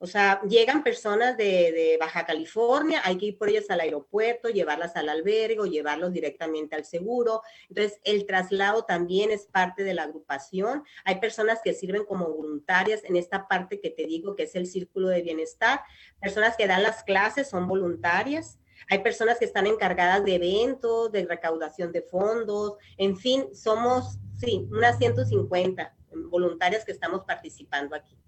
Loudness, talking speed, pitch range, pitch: -26 LUFS, 165 wpm, 170-220 Hz, 195 Hz